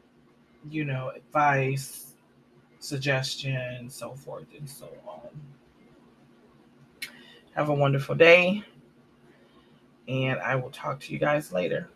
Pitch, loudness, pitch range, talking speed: 135 Hz, -25 LUFS, 125-145 Hz, 105 wpm